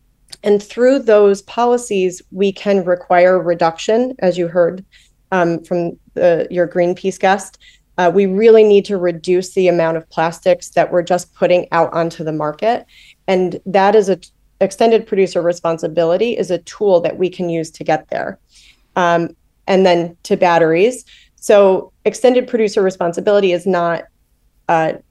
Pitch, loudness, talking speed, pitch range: 180 Hz, -15 LUFS, 155 wpm, 170-200 Hz